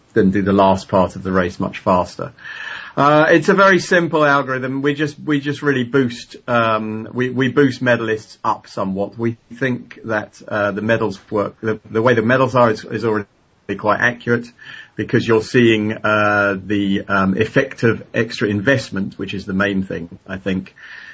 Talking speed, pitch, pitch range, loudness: 180 wpm, 110 Hz, 100-130 Hz, -17 LUFS